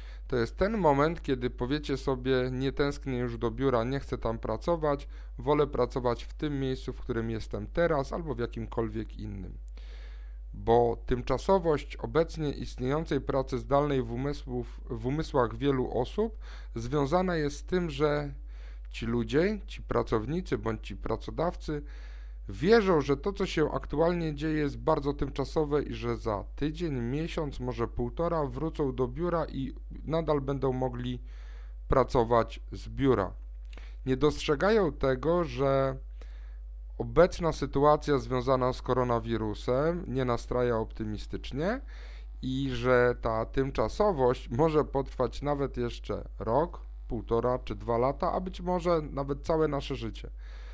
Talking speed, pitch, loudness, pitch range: 130 wpm, 130 Hz, -30 LUFS, 115-150 Hz